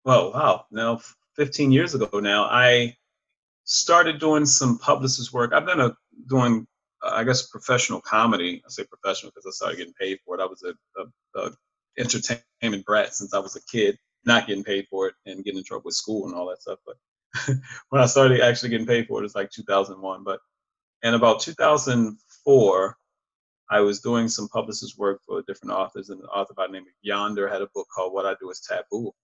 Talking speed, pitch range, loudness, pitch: 210 wpm, 100-135 Hz, -23 LUFS, 120 Hz